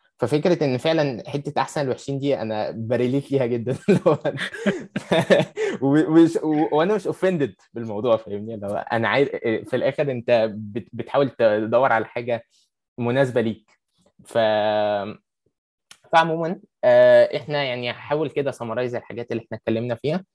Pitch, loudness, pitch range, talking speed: 130 Hz, -22 LUFS, 115-150 Hz, 110 wpm